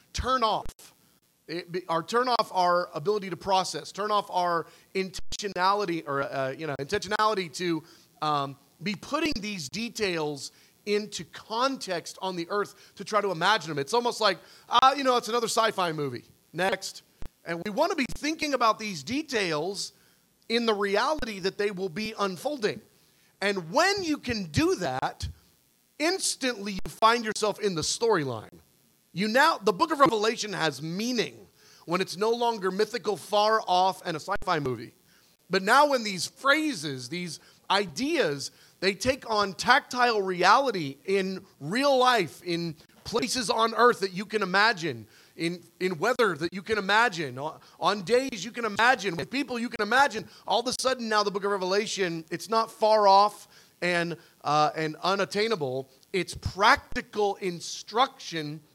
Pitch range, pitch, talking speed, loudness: 175-225 Hz, 200 Hz, 160 wpm, -27 LUFS